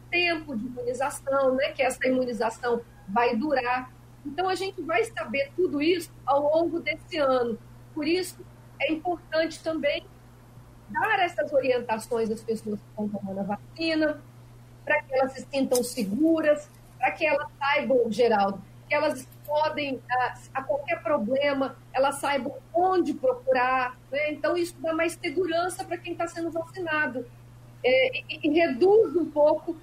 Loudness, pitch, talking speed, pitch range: -26 LUFS, 285 Hz, 150 wpm, 245-325 Hz